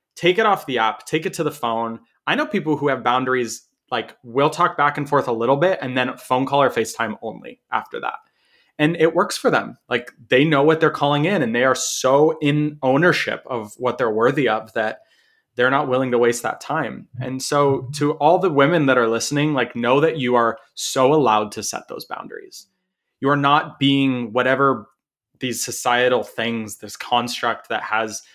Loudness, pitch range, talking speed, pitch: -20 LUFS, 120-155 Hz, 205 wpm, 135 Hz